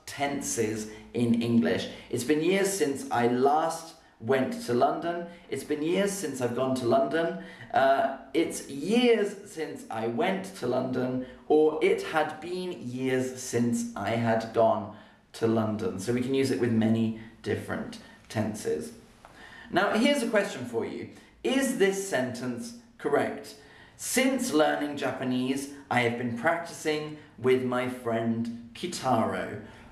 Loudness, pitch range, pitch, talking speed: -28 LUFS, 120-170 Hz, 130 Hz, 140 wpm